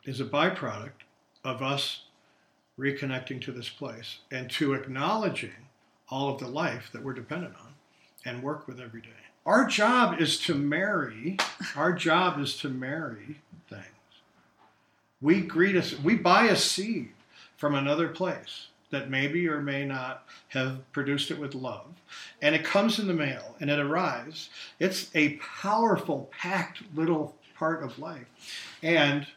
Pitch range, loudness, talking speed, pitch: 130-160 Hz, -28 LUFS, 150 wpm, 145 Hz